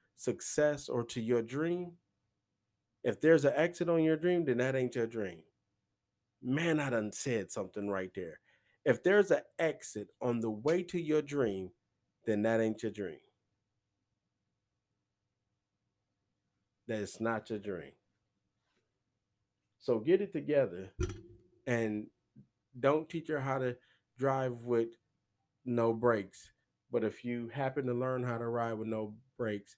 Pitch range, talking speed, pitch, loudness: 105-135 Hz, 140 wpm, 115 Hz, -34 LUFS